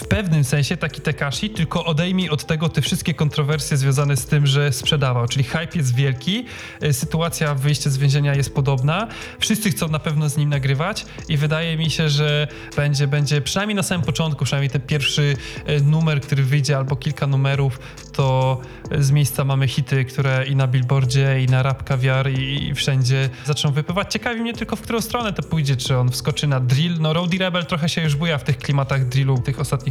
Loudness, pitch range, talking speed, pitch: -20 LUFS, 135-160 Hz, 200 wpm, 145 Hz